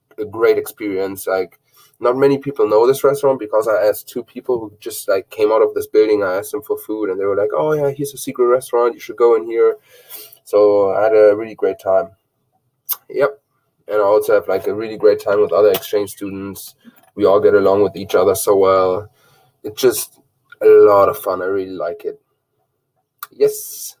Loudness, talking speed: -16 LUFS, 210 wpm